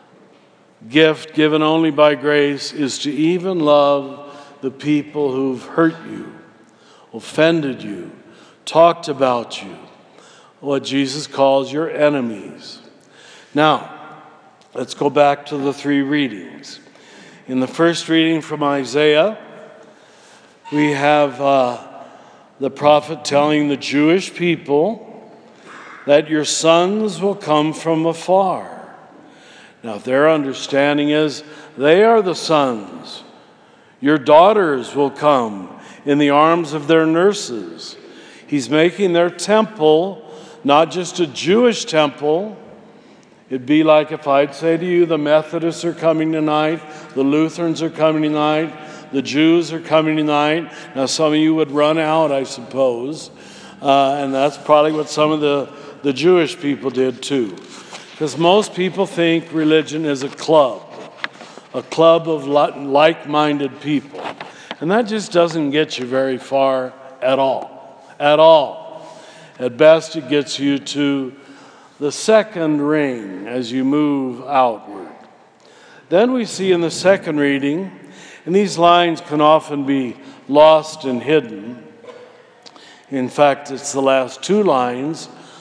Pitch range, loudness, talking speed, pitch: 140-165 Hz, -16 LUFS, 130 wpm, 150 Hz